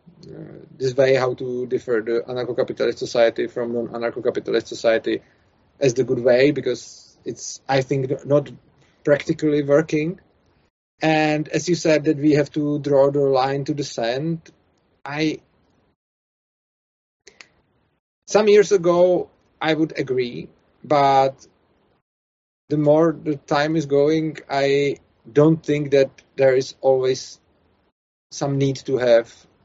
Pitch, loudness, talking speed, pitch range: 140 Hz, -20 LUFS, 130 wpm, 130-155 Hz